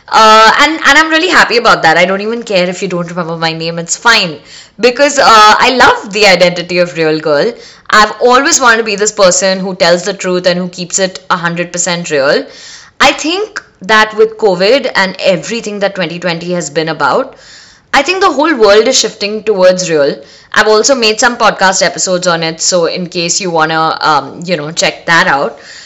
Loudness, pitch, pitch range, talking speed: -9 LUFS, 190 Hz, 175-230 Hz, 200 wpm